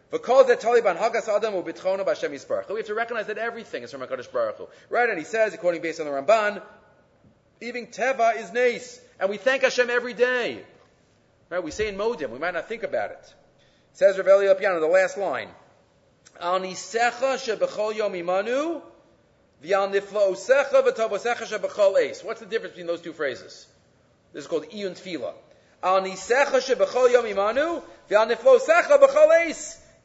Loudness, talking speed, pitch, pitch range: -23 LUFS, 190 wpm, 225 Hz, 195-260 Hz